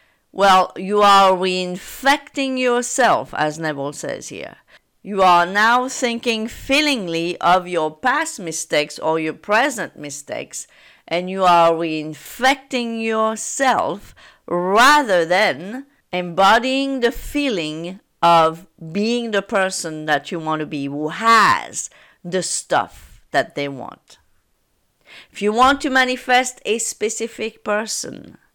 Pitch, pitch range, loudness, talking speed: 195 Hz, 165-245 Hz, -18 LUFS, 120 wpm